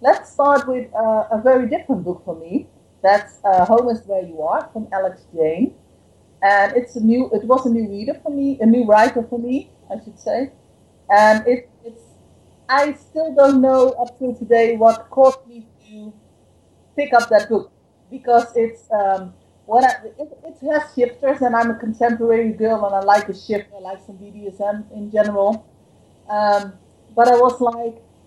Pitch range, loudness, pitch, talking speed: 210-255 Hz, -18 LUFS, 230 Hz, 185 wpm